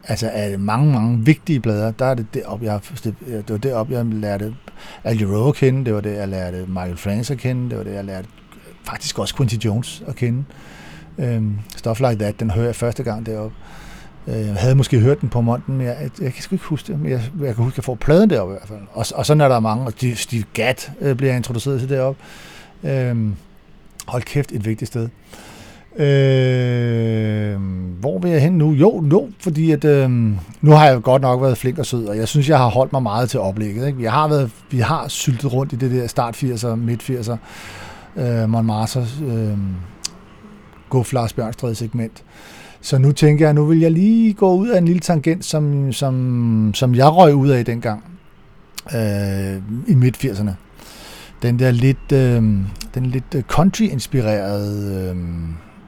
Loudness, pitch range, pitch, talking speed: -18 LUFS, 110-140 Hz, 120 Hz, 195 wpm